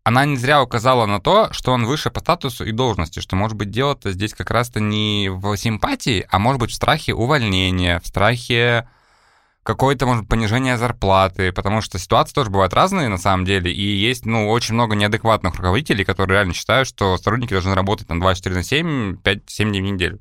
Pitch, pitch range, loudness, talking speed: 110 Hz, 95-125 Hz, -18 LUFS, 195 wpm